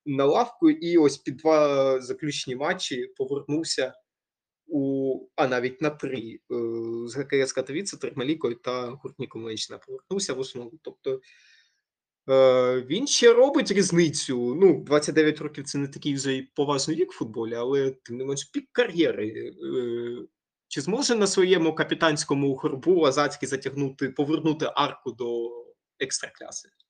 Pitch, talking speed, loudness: 150 Hz, 130 wpm, -25 LUFS